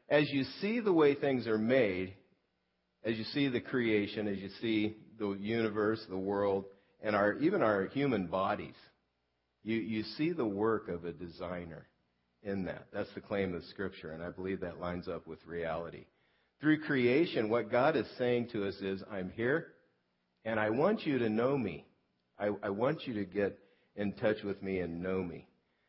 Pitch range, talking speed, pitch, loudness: 85-110 Hz, 185 wpm, 100 Hz, -34 LUFS